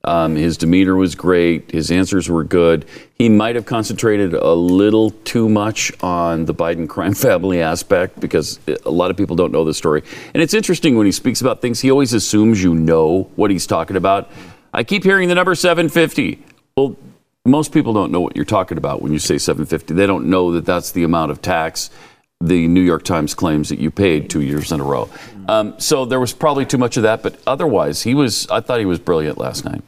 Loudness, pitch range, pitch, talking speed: -16 LUFS, 85-120 Hz, 95 Hz, 220 wpm